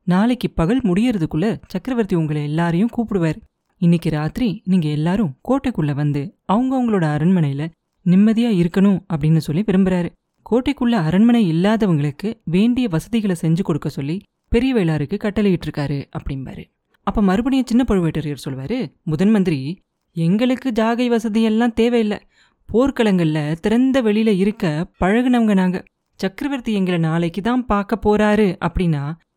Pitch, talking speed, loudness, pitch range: 190 Hz, 115 wpm, -19 LUFS, 165-230 Hz